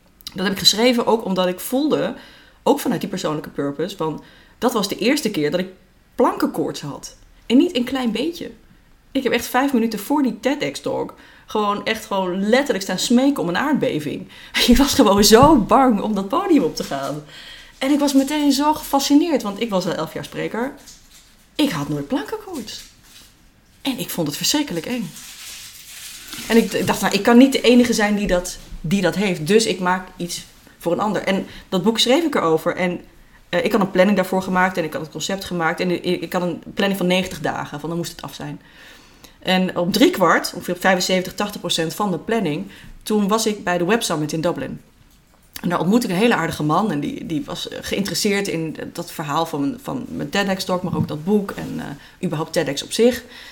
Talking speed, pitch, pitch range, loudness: 205 wpm, 195 Hz, 175-240 Hz, -19 LUFS